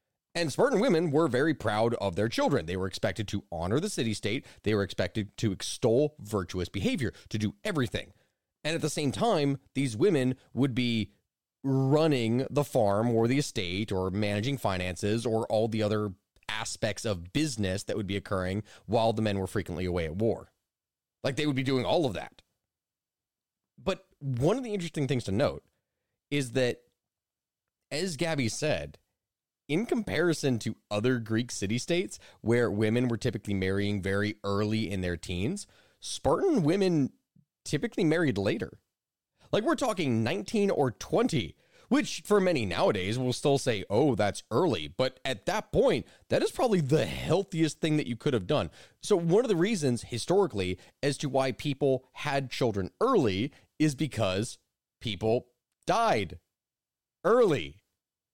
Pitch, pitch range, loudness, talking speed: 115 Hz, 100-140 Hz, -29 LUFS, 160 wpm